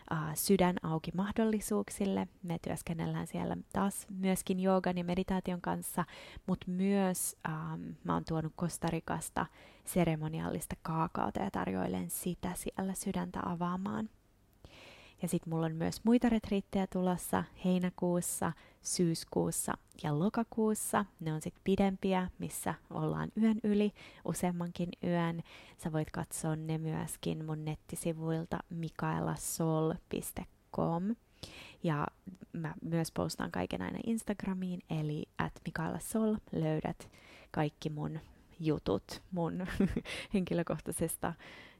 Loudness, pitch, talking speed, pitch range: -36 LUFS, 175 Hz, 105 wpm, 160-195 Hz